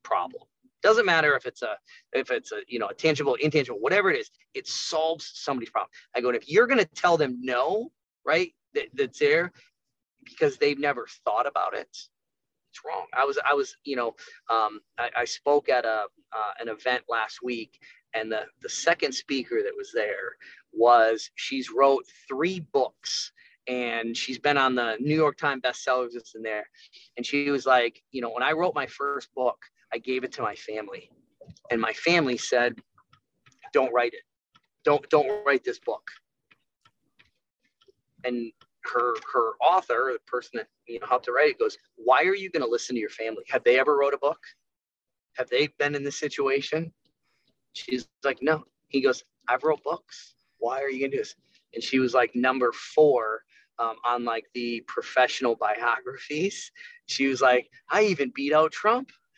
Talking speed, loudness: 185 wpm, -26 LUFS